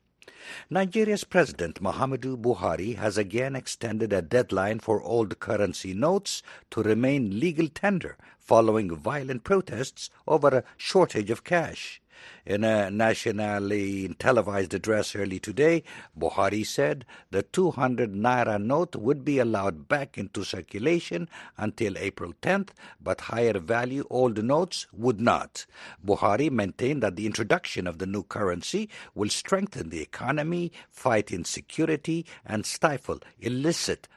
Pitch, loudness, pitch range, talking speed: 115 Hz, -27 LUFS, 105-150 Hz, 130 wpm